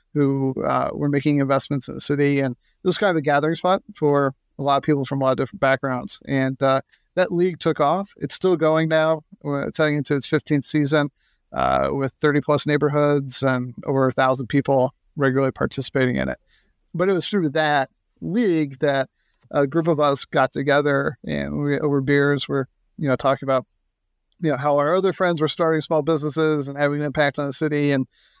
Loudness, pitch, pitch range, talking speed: -21 LUFS, 145 Hz, 135-155 Hz, 205 wpm